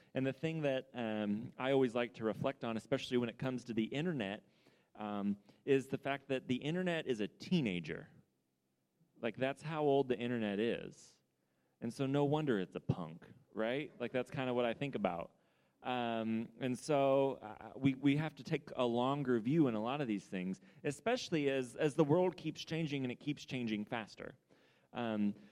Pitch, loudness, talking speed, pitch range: 130 Hz, -38 LUFS, 195 wpm, 110-140 Hz